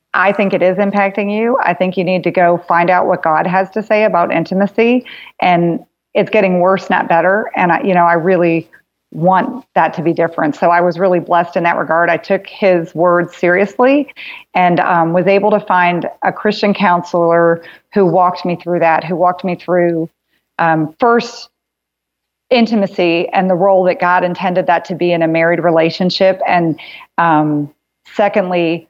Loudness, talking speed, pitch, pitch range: -13 LUFS, 185 wpm, 180 Hz, 170-195 Hz